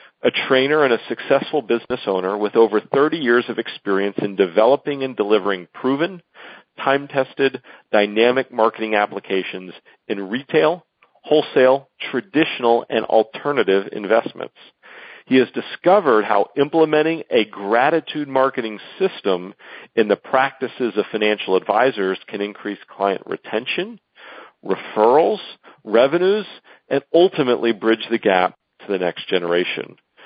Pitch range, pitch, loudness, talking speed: 105-145 Hz, 125 Hz, -19 LUFS, 115 wpm